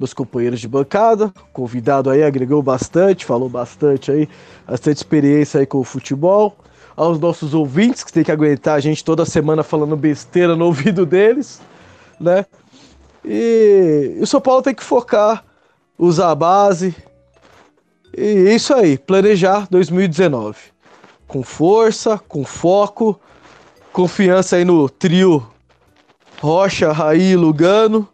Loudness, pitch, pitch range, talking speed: -15 LUFS, 170 Hz, 140-195 Hz, 130 wpm